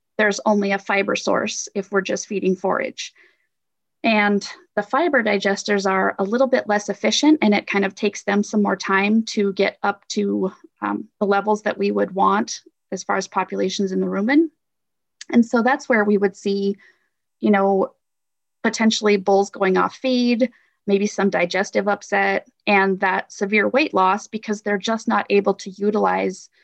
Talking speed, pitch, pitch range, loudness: 175 wpm, 205 Hz, 195-220 Hz, -20 LUFS